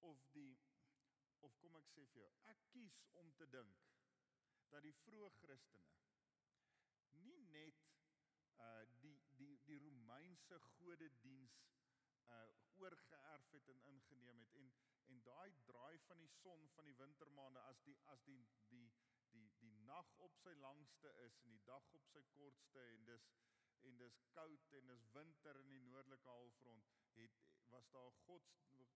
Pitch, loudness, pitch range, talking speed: 135 Hz, -67 LUFS, 125-155 Hz, 160 wpm